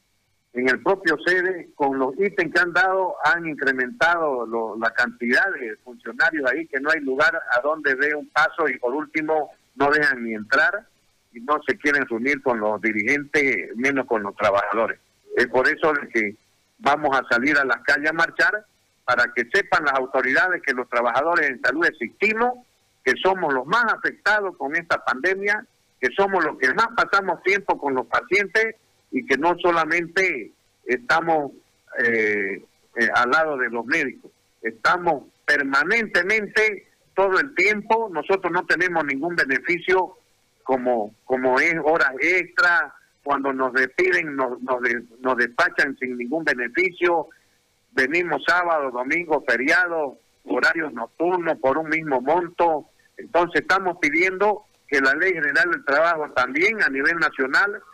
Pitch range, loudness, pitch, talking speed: 130-190 Hz, -21 LUFS, 155 Hz, 155 wpm